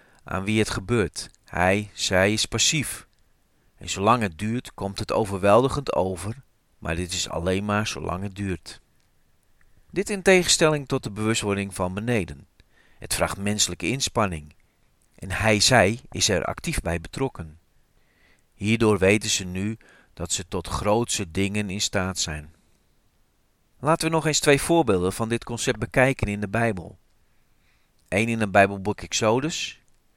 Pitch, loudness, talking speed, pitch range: 105 Hz, -23 LUFS, 145 wpm, 95-115 Hz